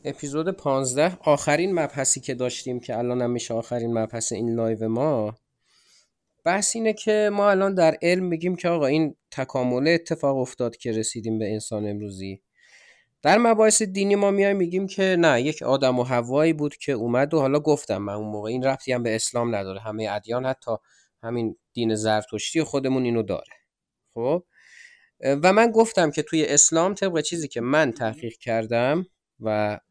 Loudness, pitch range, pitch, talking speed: -23 LUFS, 115-165 Hz, 130 Hz, 165 wpm